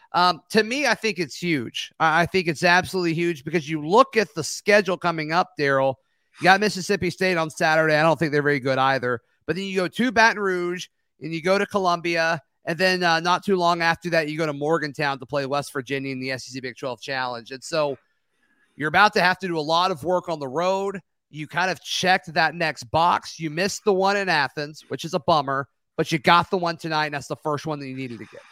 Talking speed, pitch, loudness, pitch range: 245 wpm, 165 Hz, -22 LUFS, 145-180 Hz